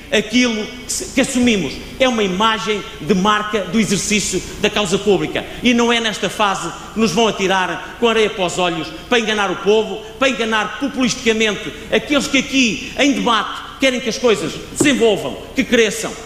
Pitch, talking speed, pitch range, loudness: 220 Hz, 170 wpm, 200-240 Hz, -17 LUFS